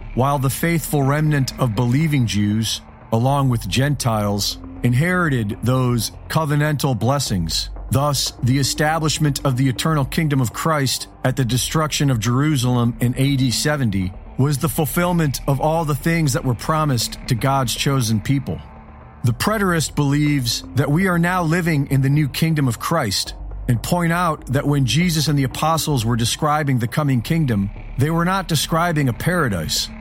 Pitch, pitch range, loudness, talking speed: 135 Hz, 120-155 Hz, -19 LUFS, 160 wpm